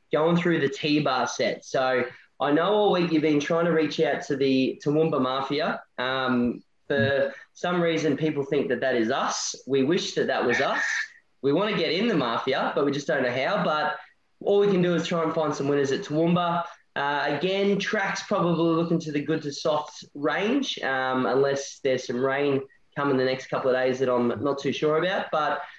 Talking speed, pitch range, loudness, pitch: 210 wpm, 135-170 Hz, -25 LUFS, 150 Hz